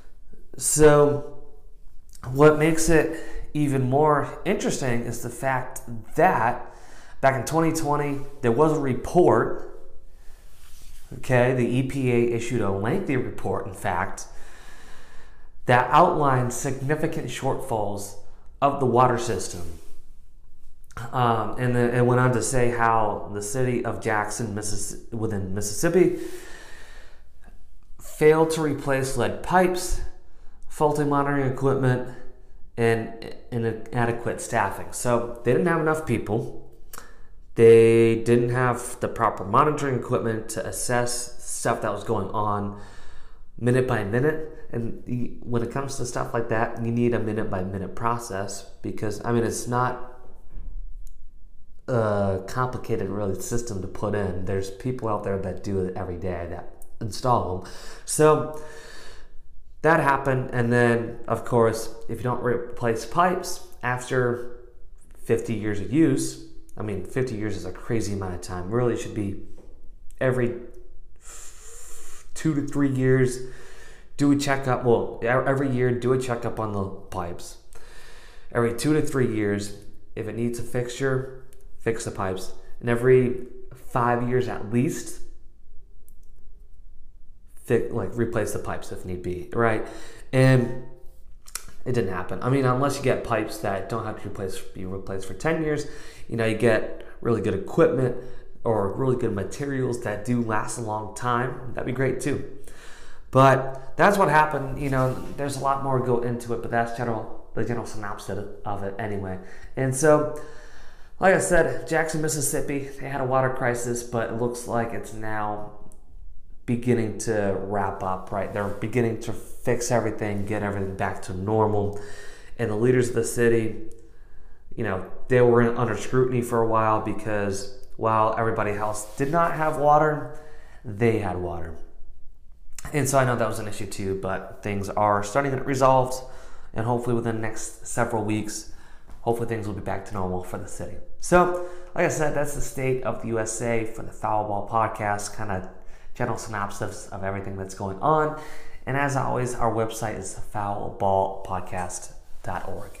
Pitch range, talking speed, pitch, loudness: 100-130 Hz, 150 wpm, 115 Hz, -25 LUFS